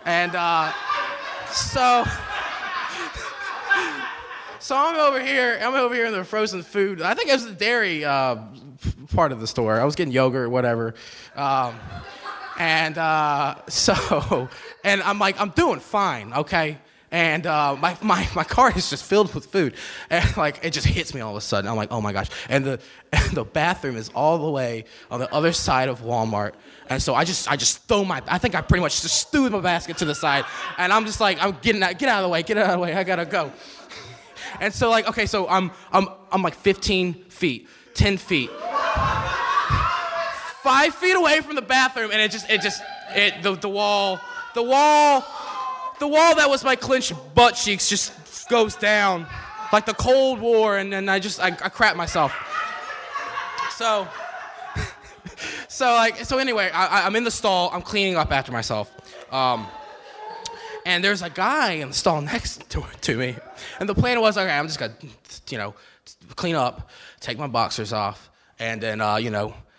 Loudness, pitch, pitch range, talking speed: -22 LUFS, 195 Hz, 150-230 Hz, 195 wpm